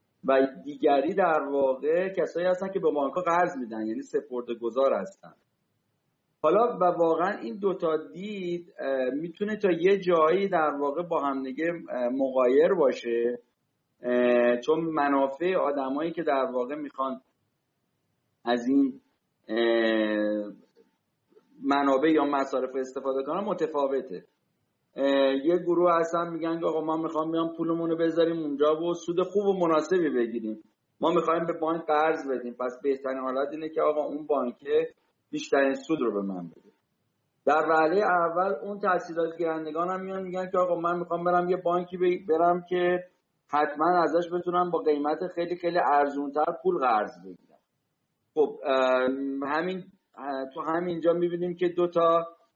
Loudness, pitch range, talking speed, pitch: -27 LUFS, 135-175 Hz, 140 wpm, 160 Hz